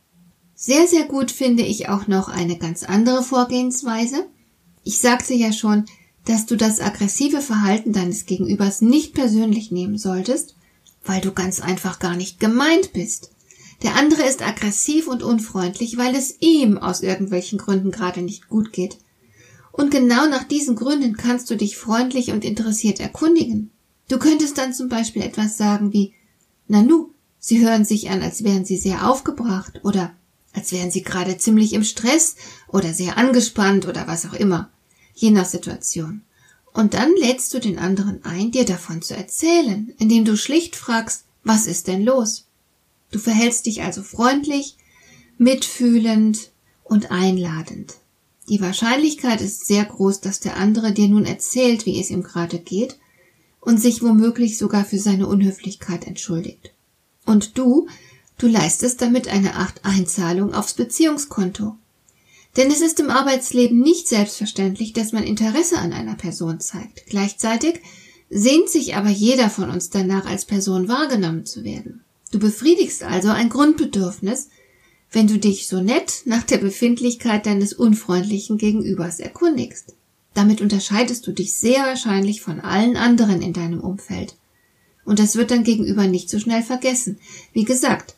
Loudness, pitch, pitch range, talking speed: -19 LUFS, 215 Hz, 190-245 Hz, 155 wpm